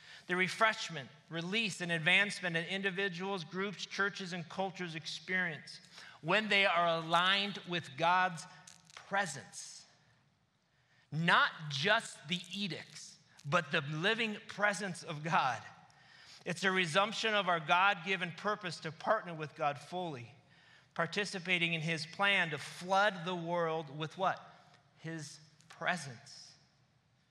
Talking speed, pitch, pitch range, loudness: 120 wpm, 175 Hz, 160-195 Hz, -34 LUFS